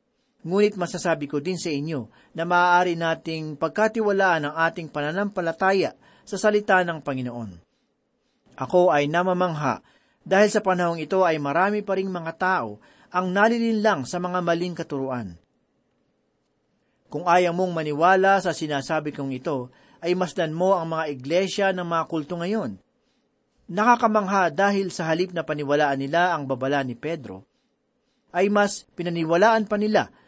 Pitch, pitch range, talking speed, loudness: 175 Hz, 155-195 Hz, 140 wpm, -23 LUFS